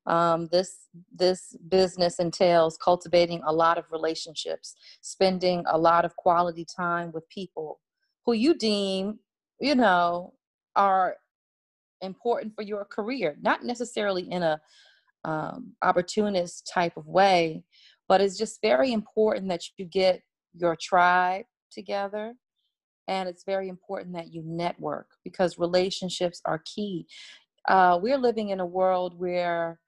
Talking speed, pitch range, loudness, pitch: 135 wpm, 170-205 Hz, -26 LUFS, 180 Hz